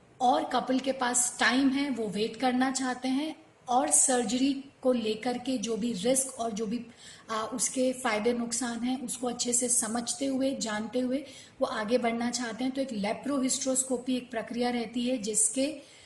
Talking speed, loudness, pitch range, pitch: 175 wpm, -29 LUFS, 235-260 Hz, 250 Hz